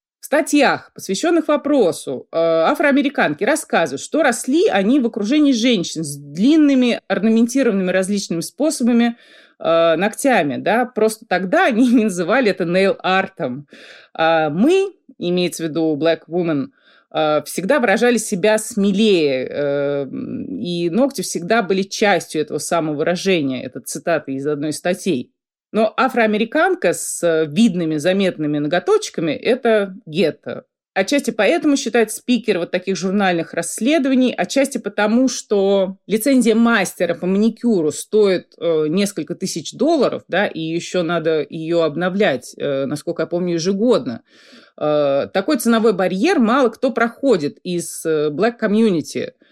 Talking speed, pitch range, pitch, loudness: 120 wpm, 165-240 Hz, 195 Hz, -18 LUFS